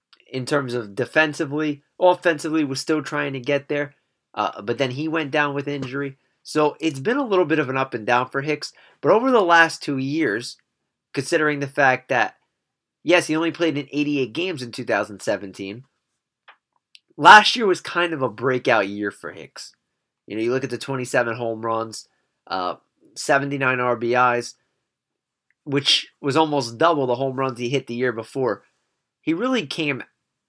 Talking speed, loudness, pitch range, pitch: 175 wpm, -21 LUFS, 125-155 Hz, 140 Hz